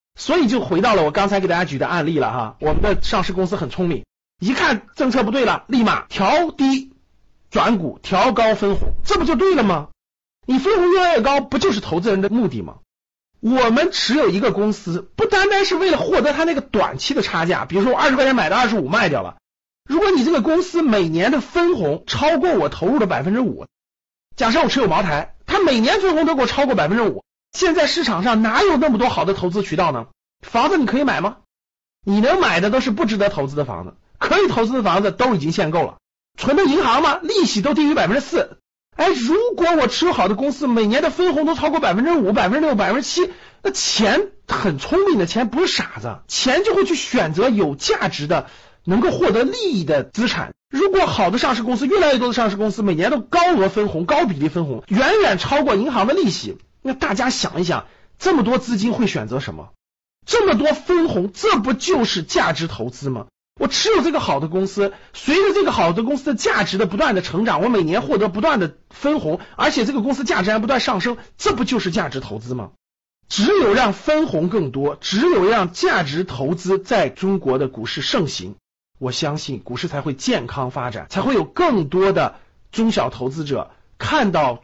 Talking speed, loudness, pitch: 320 characters per minute, -18 LUFS, 235 Hz